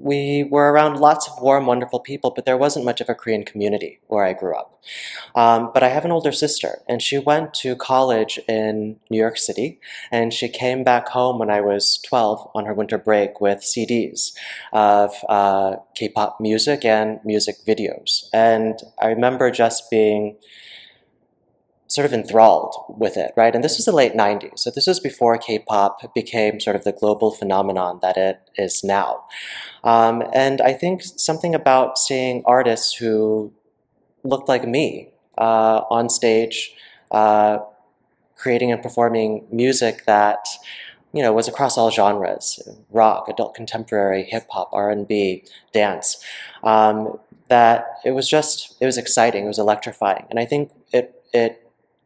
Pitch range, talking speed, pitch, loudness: 105-125 Hz, 160 wpm, 115 Hz, -19 LUFS